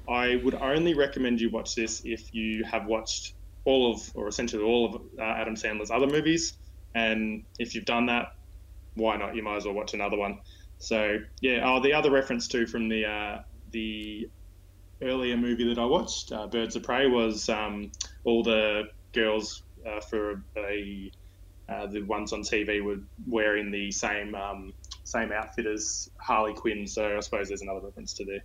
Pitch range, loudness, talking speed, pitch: 100-115 Hz, -29 LUFS, 190 wpm, 105 Hz